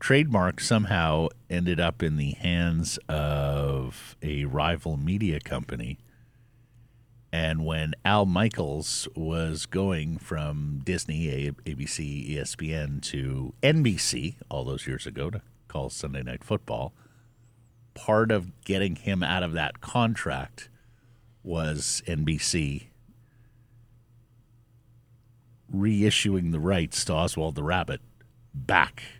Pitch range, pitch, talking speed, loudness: 80-120 Hz, 95 Hz, 105 wpm, -28 LUFS